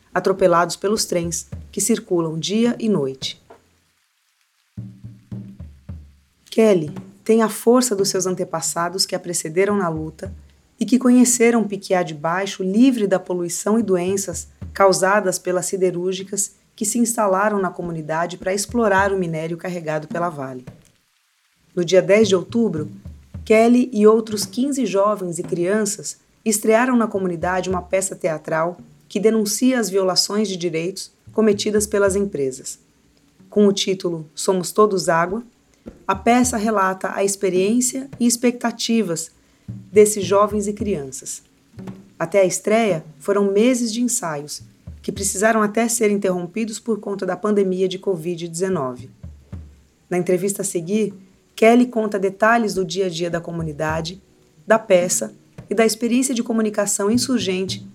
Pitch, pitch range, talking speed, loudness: 190 Hz, 170-215 Hz, 135 wpm, -19 LUFS